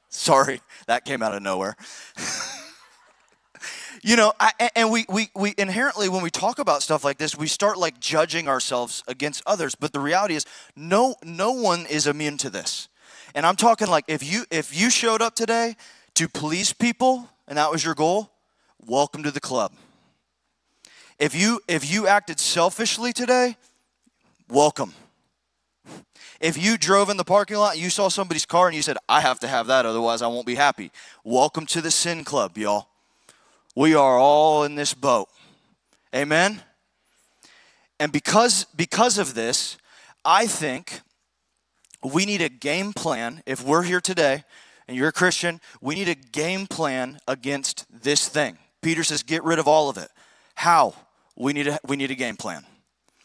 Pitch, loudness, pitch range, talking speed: 160 Hz, -22 LUFS, 140-200 Hz, 170 wpm